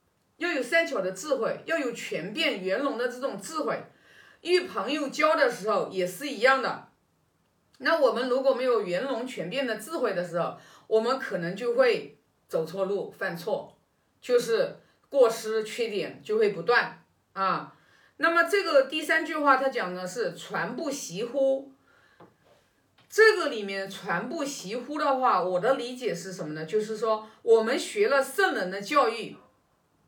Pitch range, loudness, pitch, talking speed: 215-320 Hz, -27 LUFS, 265 Hz, 230 characters per minute